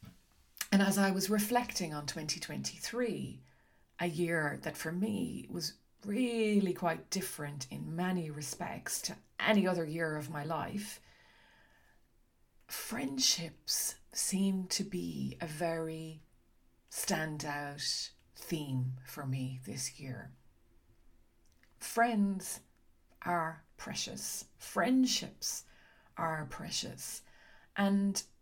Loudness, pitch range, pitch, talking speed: -35 LUFS, 145-195 Hz, 165 Hz, 95 wpm